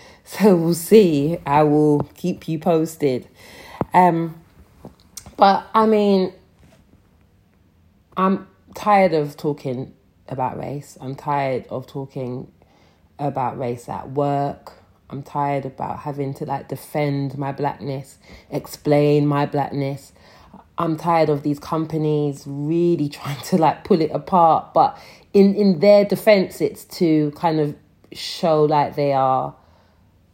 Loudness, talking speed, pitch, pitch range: -20 LUFS, 125 wpm, 145 Hz, 130-165 Hz